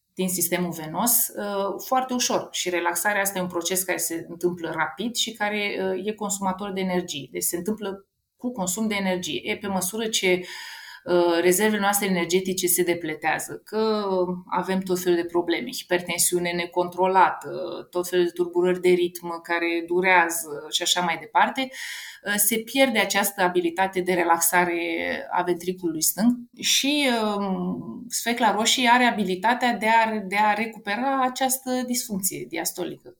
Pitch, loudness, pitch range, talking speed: 185 Hz, -23 LUFS, 175-215 Hz, 145 wpm